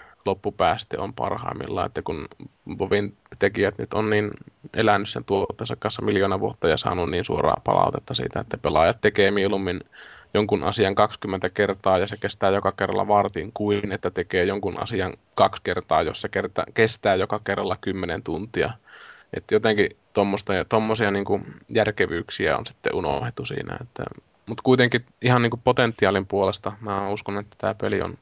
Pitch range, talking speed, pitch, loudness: 100-110 Hz, 150 wpm, 100 Hz, -24 LUFS